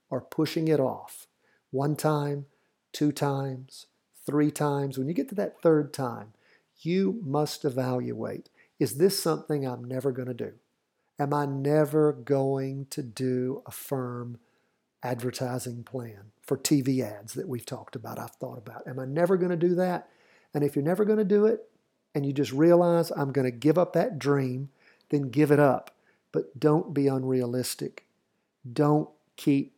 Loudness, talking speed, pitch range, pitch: -27 LUFS, 170 wpm, 130-155 Hz, 140 Hz